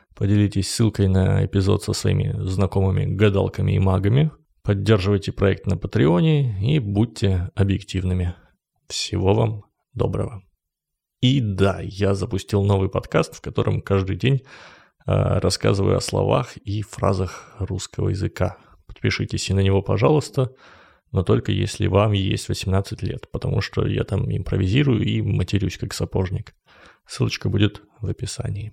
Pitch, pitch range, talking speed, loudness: 100 Hz, 95-115 Hz, 130 wpm, -22 LUFS